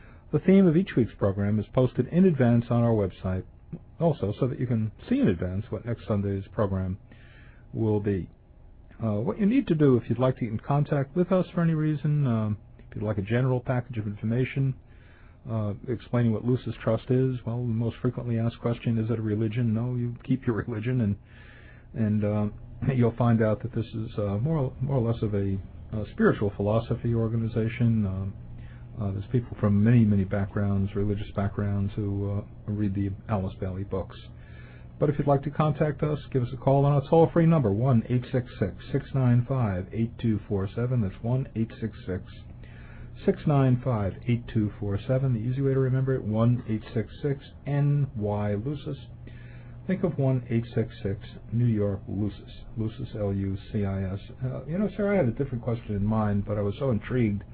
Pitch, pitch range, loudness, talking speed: 115 Hz, 105-130 Hz, -27 LUFS, 180 wpm